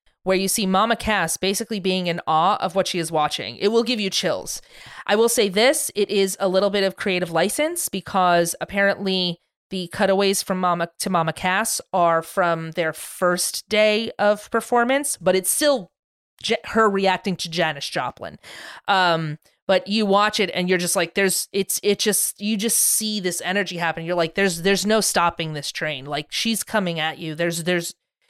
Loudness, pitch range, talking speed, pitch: -21 LUFS, 170-210 Hz, 190 wpm, 190 Hz